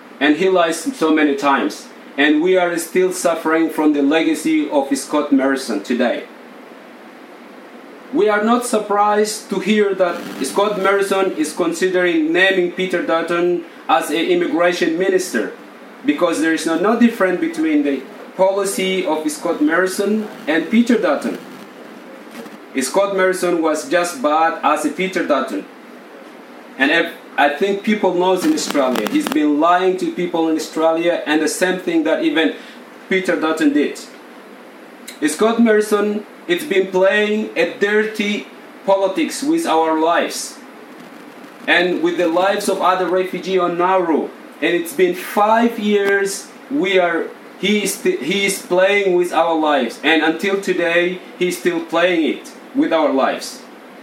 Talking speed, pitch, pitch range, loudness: 145 wpm, 190 Hz, 170-225 Hz, -17 LUFS